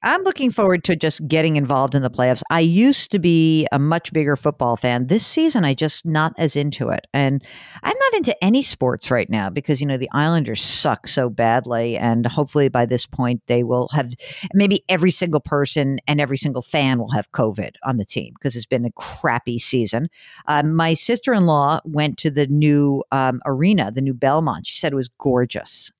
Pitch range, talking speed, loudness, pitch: 125-160 Hz, 210 wpm, -19 LUFS, 145 Hz